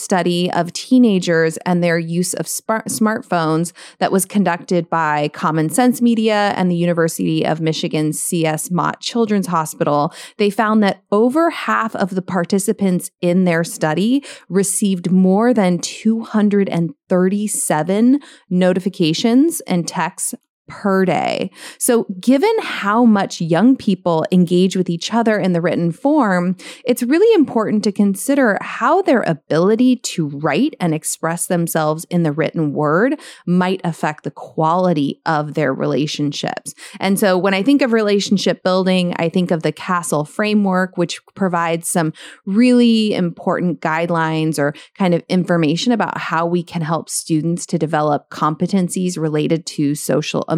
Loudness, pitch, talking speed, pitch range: -17 LUFS, 180 Hz, 140 wpm, 165-215 Hz